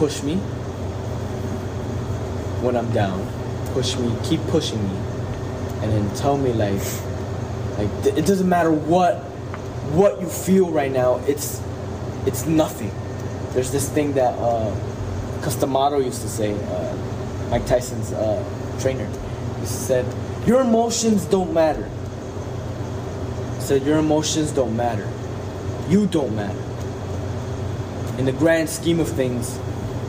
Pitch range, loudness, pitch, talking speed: 105-130 Hz, -22 LUFS, 125 Hz, 130 wpm